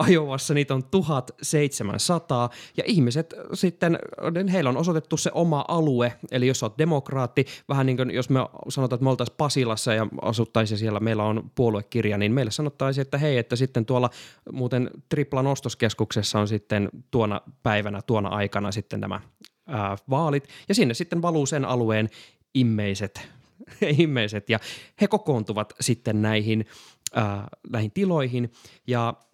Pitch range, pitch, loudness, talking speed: 110-145 Hz, 125 Hz, -25 LUFS, 145 wpm